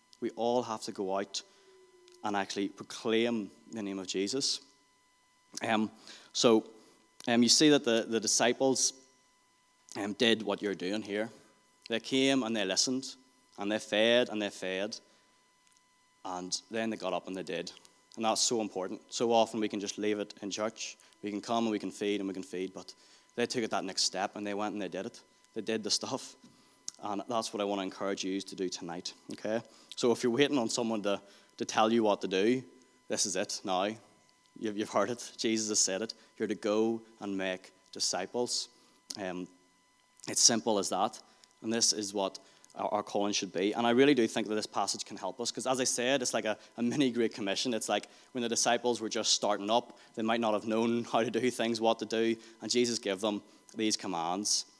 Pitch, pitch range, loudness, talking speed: 110 Hz, 100-120 Hz, -31 LUFS, 215 wpm